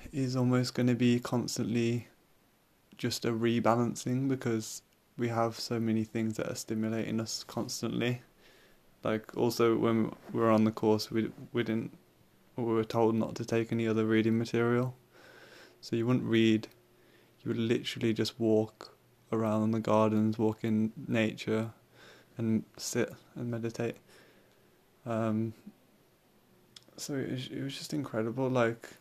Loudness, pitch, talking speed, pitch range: -31 LUFS, 115 Hz, 145 wpm, 110-120 Hz